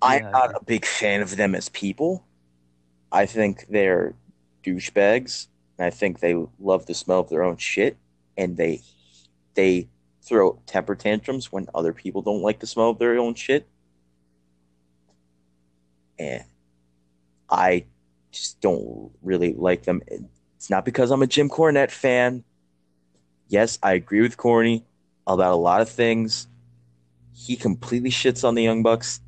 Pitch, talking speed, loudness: 90 Hz, 150 wpm, -22 LUFS